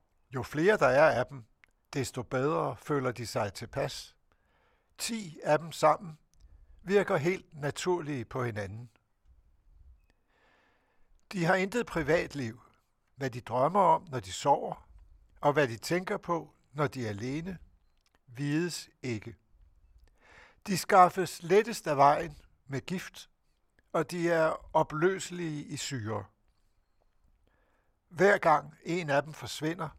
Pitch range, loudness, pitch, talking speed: 105-170 Hz, -30 LUFS, 140 Hz, 125 wpm